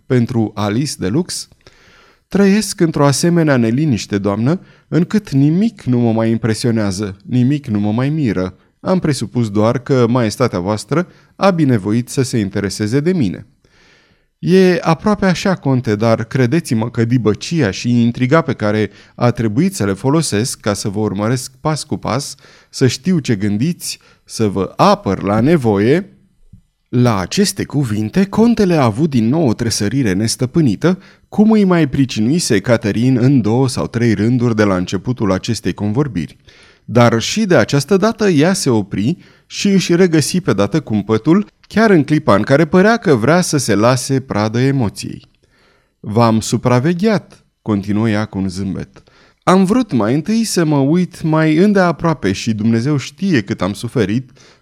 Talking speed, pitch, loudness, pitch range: 155 wpm, 125 Hz, -15 LUFS, 110-165 Hz